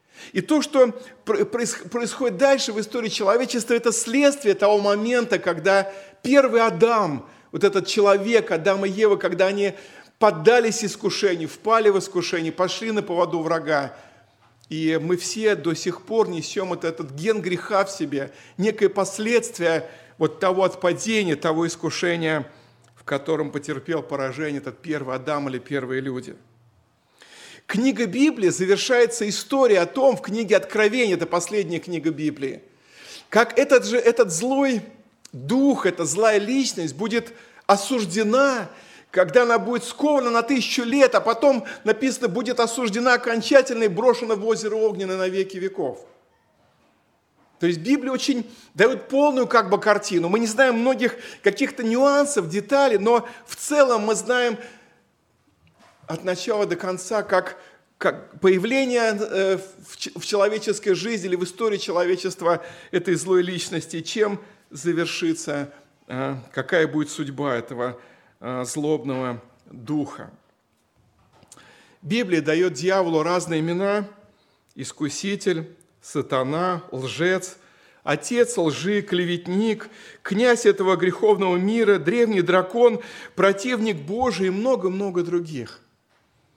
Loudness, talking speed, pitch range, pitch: -22 LUFS, 120 wpm, 170-230 Hz, 195 Hz